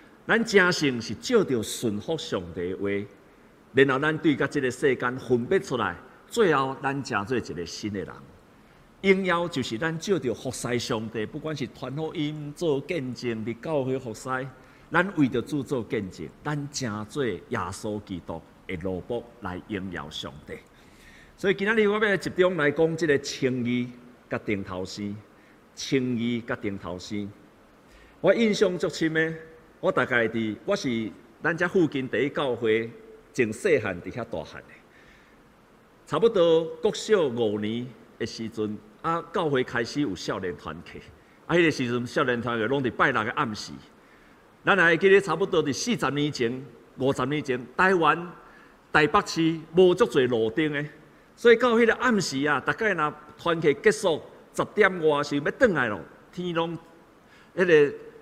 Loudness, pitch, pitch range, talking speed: -26 LUFS, 140 Hz, 120-175 Hz, 235 characters per minute